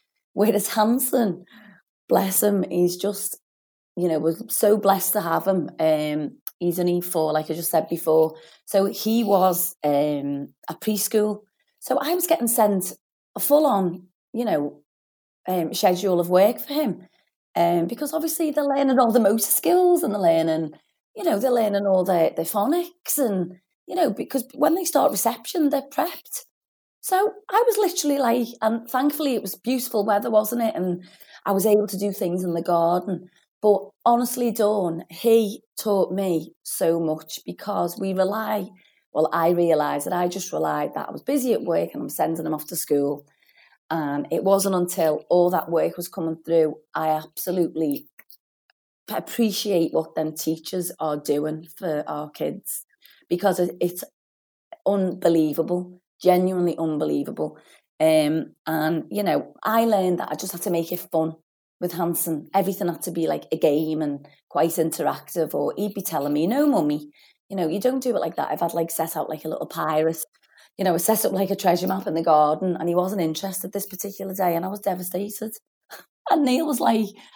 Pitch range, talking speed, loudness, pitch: 165-220 Hz, 180 wpm, -23 LUFS, 185 Hz